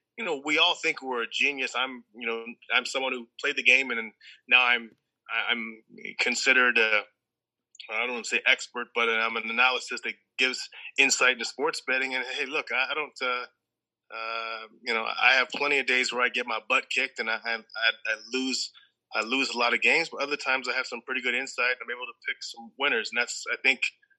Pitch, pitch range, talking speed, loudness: 125 Hz, 115-130 Hz, 230 wpm, -26 LUFS